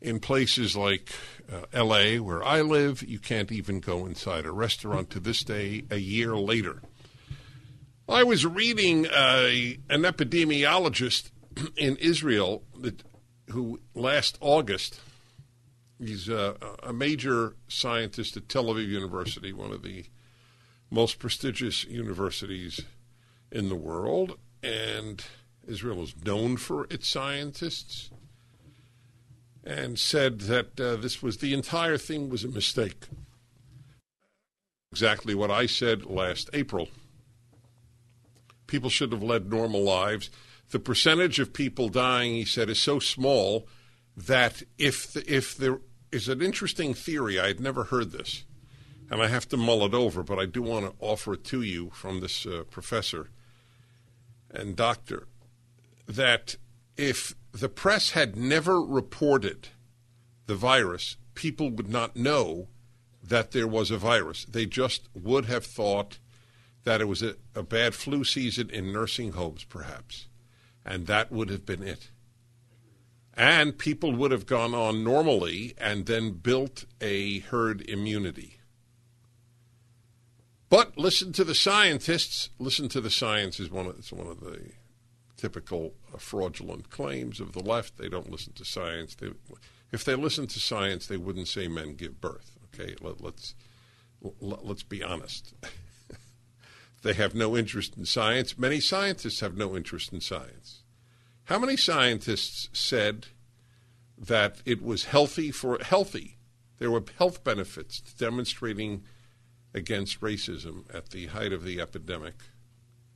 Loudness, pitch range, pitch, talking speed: -27 LUFS, 110-130 Hz, 120 Hz, 140 wpm